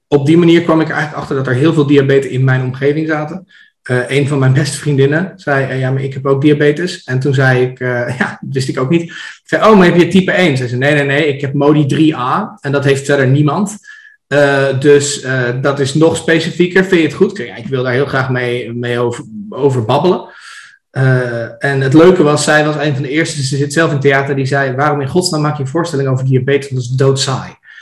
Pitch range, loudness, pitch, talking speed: 135-165 Hz, -12 LUFS, 145 Hz, 250 wpm